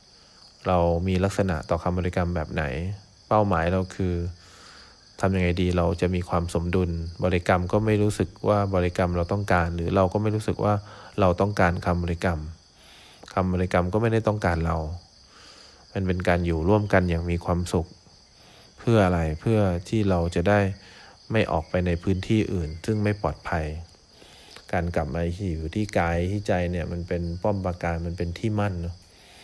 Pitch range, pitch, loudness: 85-100 Hz, 90 Hz, -25 LUFS